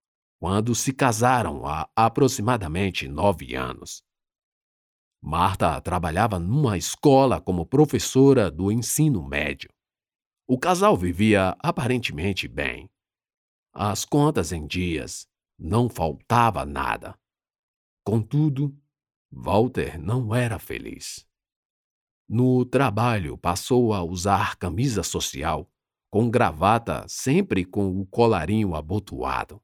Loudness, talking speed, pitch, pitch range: -23 LUFS, 95 wpm, 105 Hz, 90-125 Hz